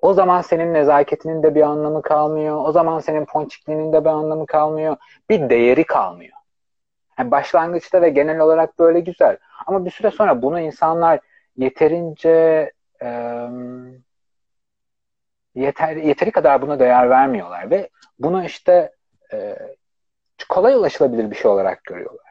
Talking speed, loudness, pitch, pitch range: 135 wpm, -17 LUFS, 155 Hz, 150-175 Hz